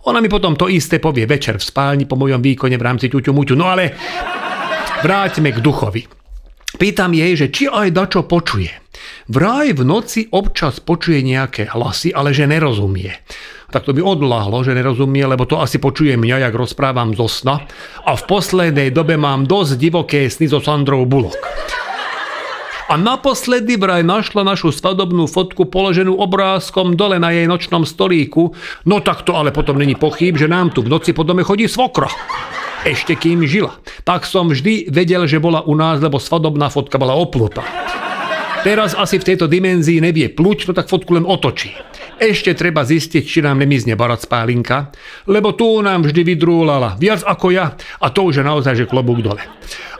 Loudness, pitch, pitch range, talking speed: -14 LUFS, 160 Hz, 135-185 Hz, 175 wpm